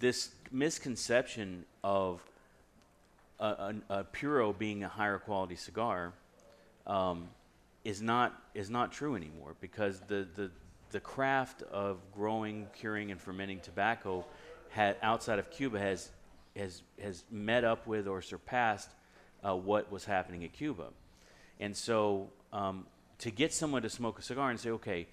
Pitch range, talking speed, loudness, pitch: 95-115 Hz, 145 wpm, -36 LUFS, 105 Hz